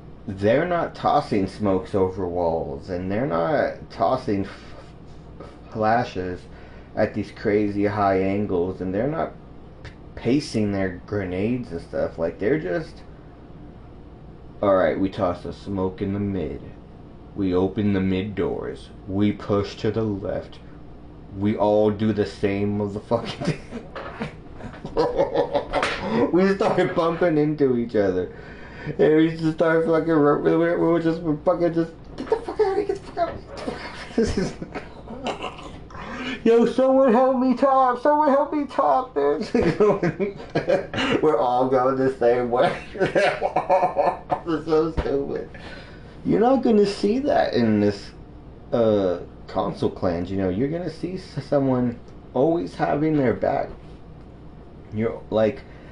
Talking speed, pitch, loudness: 140 wpm, 130 Hz, -23 LUFS